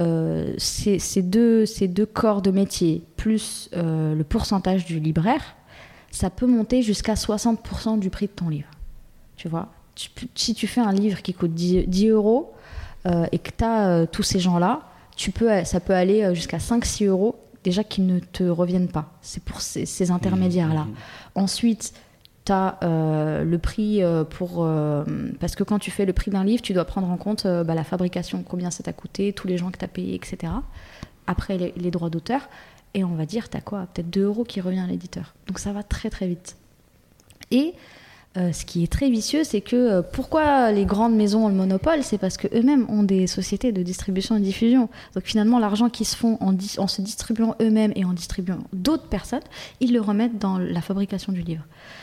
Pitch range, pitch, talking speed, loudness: 180-220 Hz, 195 Hz, 210 wpm, -23 LUFS